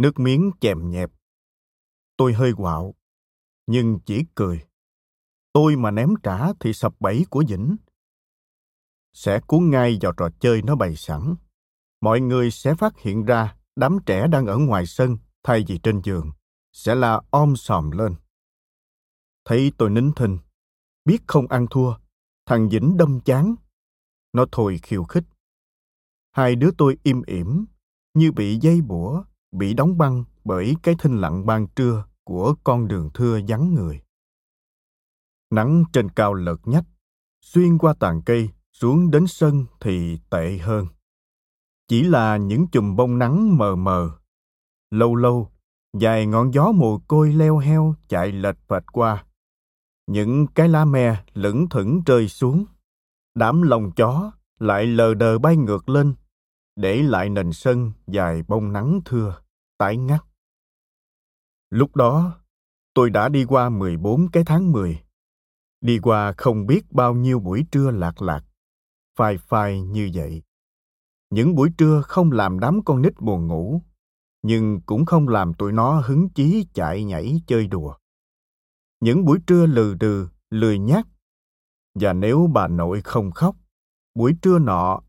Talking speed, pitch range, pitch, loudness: 150 wpm, 100-150 Hz, 120 Hz, -20 LUFS